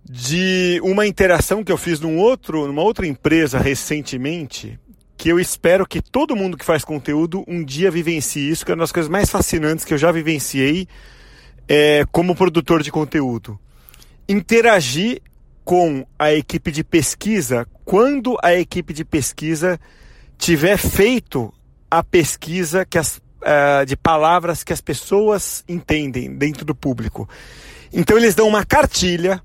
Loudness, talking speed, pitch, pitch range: -17 LUFS, 150 wpm, 165 Hz, 145-185 Hz